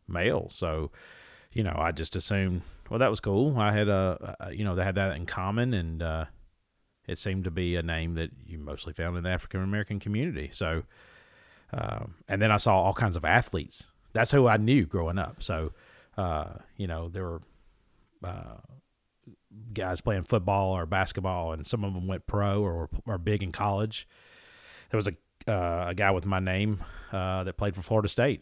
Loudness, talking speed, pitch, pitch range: -29 LUFS, 195 wpm, 95 Hz, 85-105 Hz